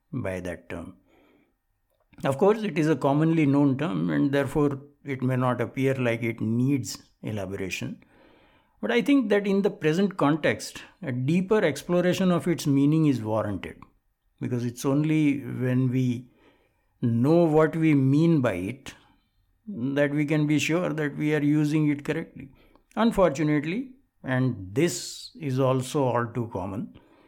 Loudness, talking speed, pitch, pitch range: -25 LUFS, 145 wpm, 145 Hz, 125-160 Hz